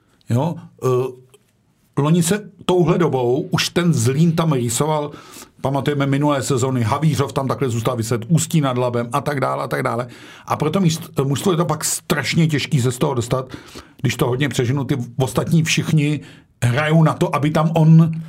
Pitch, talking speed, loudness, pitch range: 145 Hz, 170 wpm, -19 LUFS, 130-160 Hz